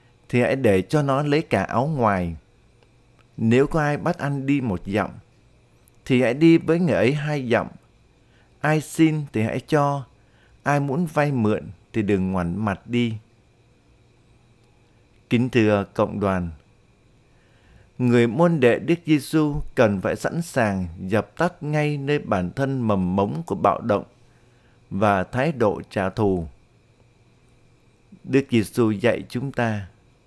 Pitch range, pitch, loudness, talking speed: 105-145 Hz, 120 Hz, -22 LUFS, 145 wpm